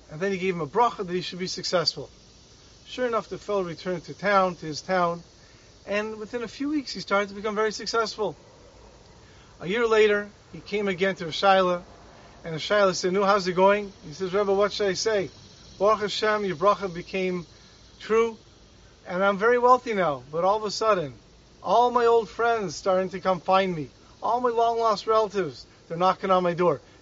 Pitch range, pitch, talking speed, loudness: 175-215 Hz, 195 Hz, 200 wpm, -25 LUFS